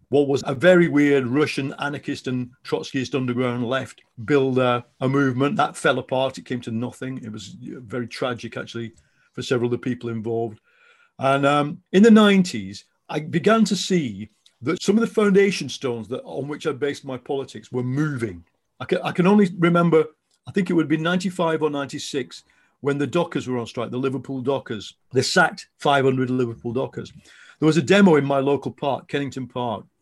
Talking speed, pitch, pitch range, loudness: 190 wpm, 140 Hz, 125-160 Hz, -22 LUFS